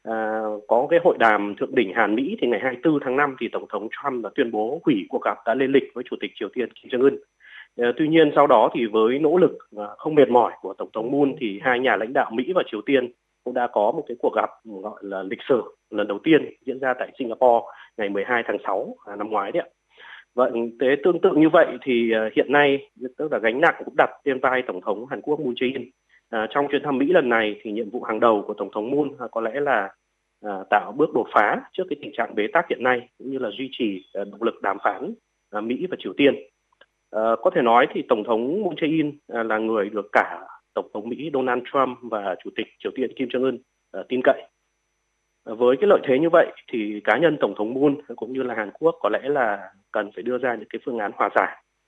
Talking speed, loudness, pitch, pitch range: 255 wpm, -22 LUFS, 120 Hz, 110-140 Hz